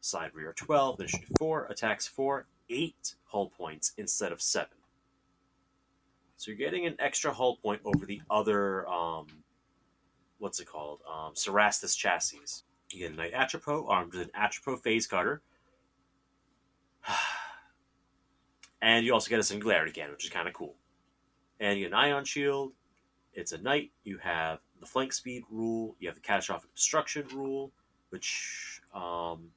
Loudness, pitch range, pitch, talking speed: -31 LUFS, 90-135 Hz, 110 Hz, 155 wpm